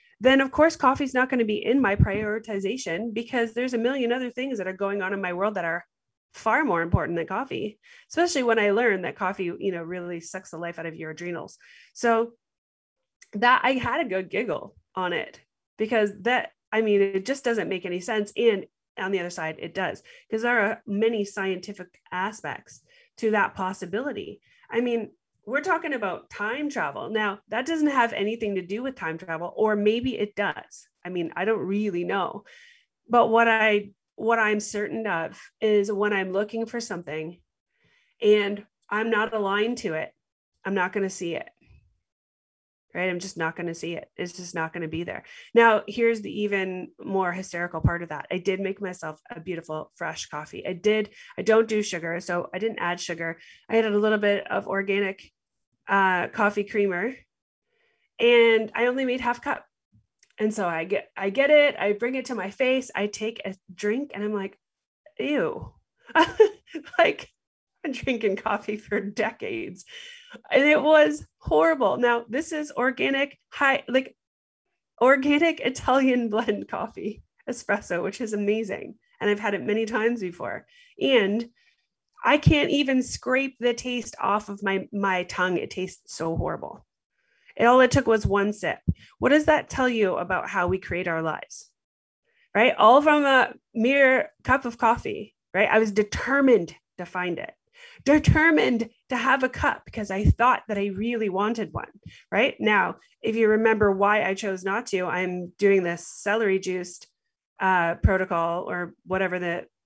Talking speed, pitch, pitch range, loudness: 180 wpm, 210 Hz, 190-245 Hz, -24 LUFS